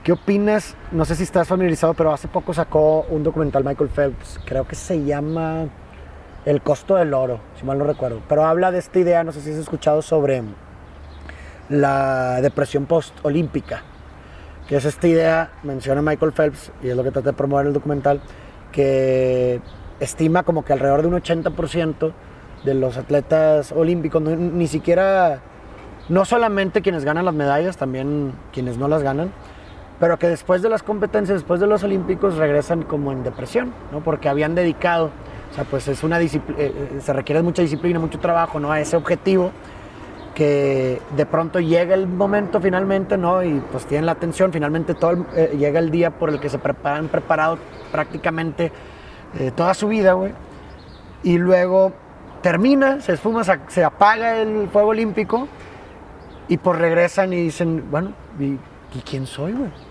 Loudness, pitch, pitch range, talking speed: -19 LUFS, 160 Hz, 140-175 Hz, 170 wpm